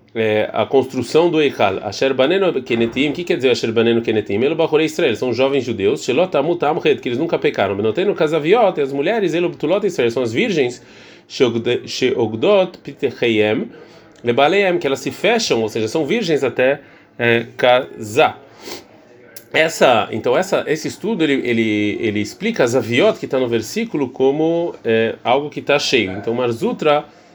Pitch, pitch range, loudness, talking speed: 135 Hz, 115-165 Hz, -17 LUFS, 120 wpm